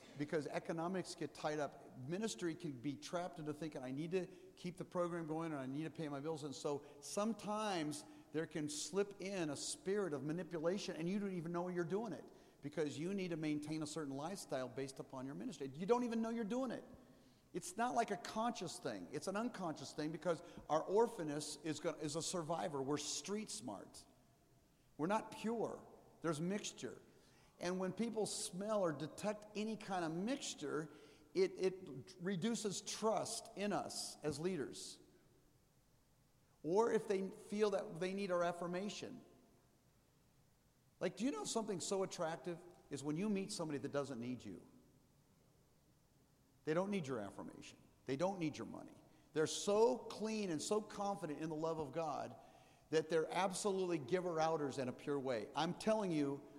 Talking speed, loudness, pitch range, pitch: 175 wpm, -42 LUFS, 150-200 Hz, 175 Hz